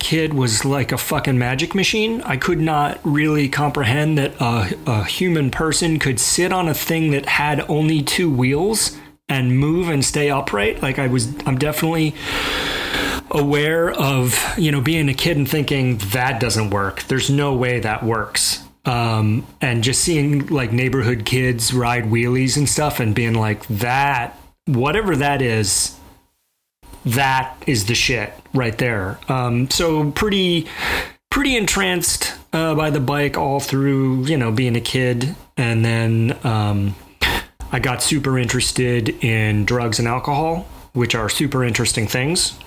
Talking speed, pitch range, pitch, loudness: 155 wpm, 120-150 Hz, 135 Hz, -18 LUFS